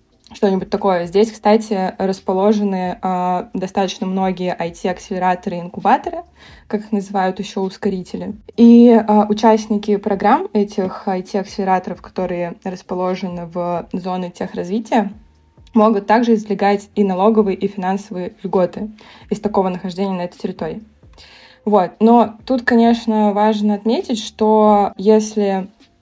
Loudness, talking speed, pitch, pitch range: -17 LUFS, 115 wpm, 200 Hz, 185-215 Hz